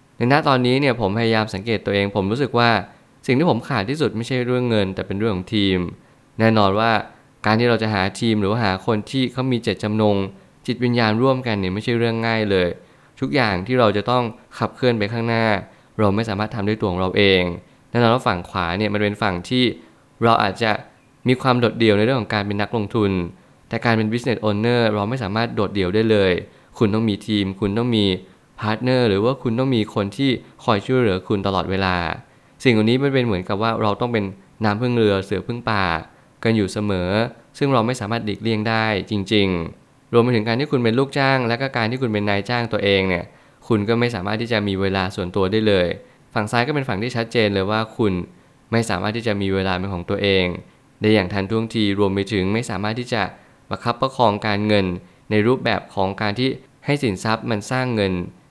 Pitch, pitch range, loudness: 110 Hz, 100-120 Hz, -20 LUFS